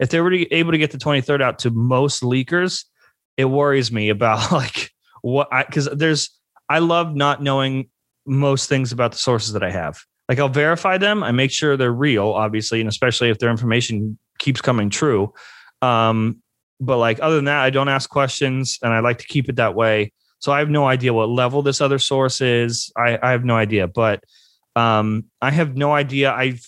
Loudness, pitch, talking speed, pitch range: -18 LUFS, 130 Hz, 205 wpm, 115-145 Hz